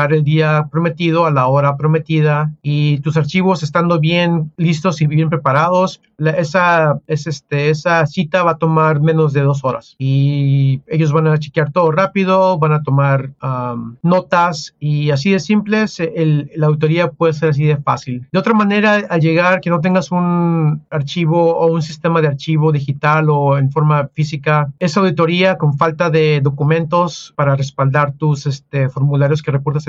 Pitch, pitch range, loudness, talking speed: 155 Hz, 145-170 Hz, -15 LUFS, 175 wpm